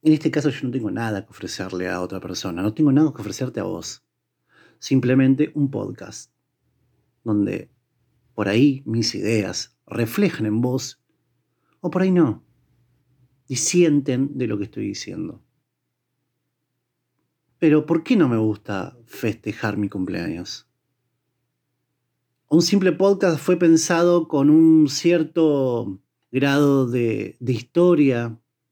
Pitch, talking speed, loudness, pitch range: 130 Hz, 130 wpm, -20 LUFS, 110-155 Hz